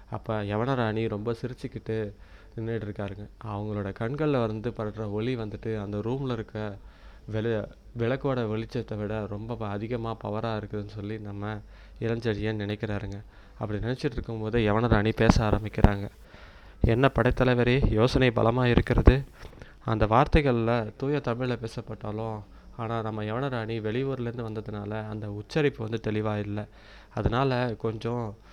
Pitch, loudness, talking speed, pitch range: 110 Hz, -28 LUFS, 115 wpm, 105-120 Hz